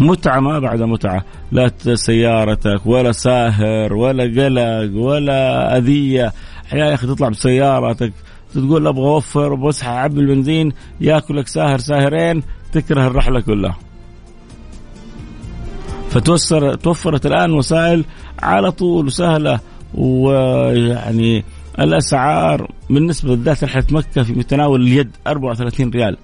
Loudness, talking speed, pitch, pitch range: -15 LUFS, 105 wpm, 130 Hz, 115-150 Hz